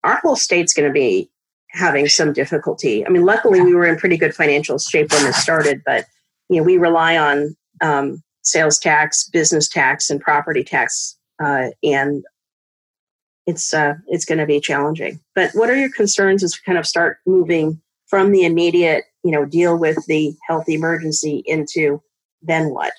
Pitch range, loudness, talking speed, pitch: 155-185 Hz, -16 LUFS, 180 wpm, 165 Hz